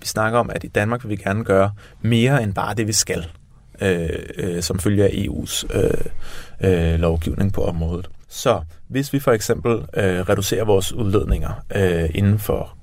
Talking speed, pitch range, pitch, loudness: 180 wpm, 85-110 Hz, 100 Hz, -20 LUFS